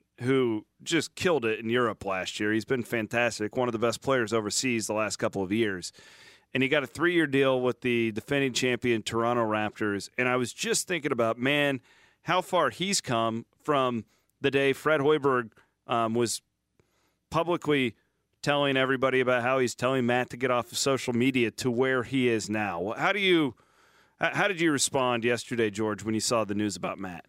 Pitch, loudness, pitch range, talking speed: 125 Hz, -27 LUFS, 115-135 Hz, 190 wpm